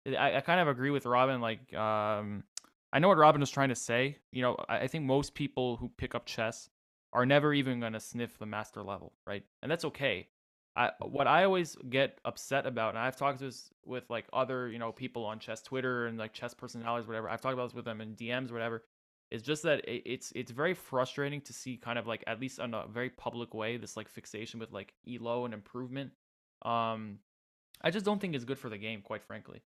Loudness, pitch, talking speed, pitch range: -34 LUFS, 120 Hz, 230 wpm, 110-130 Hz